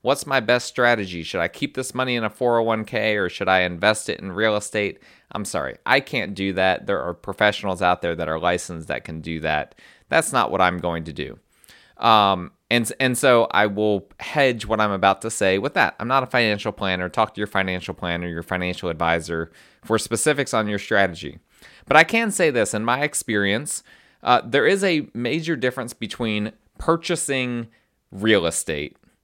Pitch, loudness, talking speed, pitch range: 105 Hz, -21 LUFS, 200 wpm, 90-120 Hz